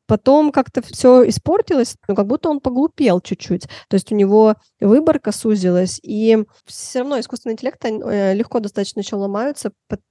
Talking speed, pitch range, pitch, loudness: 155 wpm, 205-260 Hz, 225 Hz, -17 LUFS